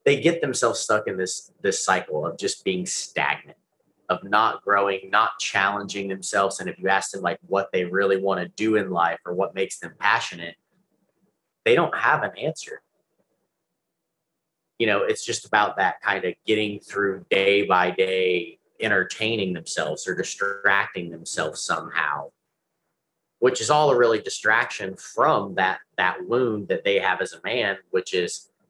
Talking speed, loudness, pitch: 165 wpm, -23 LUFS, 100 Hz